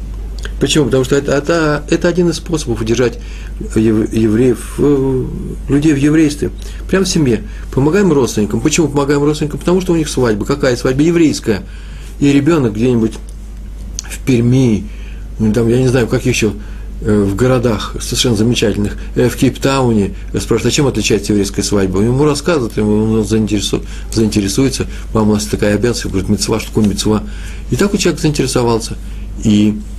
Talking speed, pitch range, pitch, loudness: 155 wpm, 105-140 Hz, 115 Hz, -14 LUFS